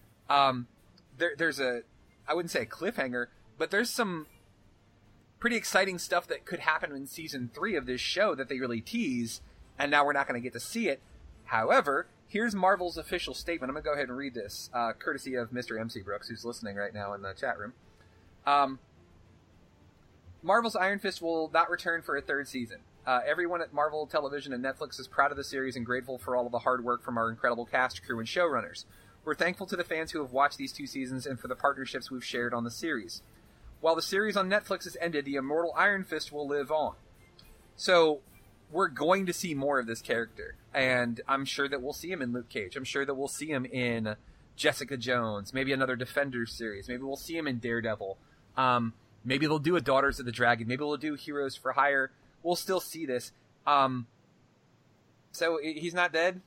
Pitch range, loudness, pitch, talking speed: 120-160 Hz, -31 LUFS, 135 Hz, 210 wpm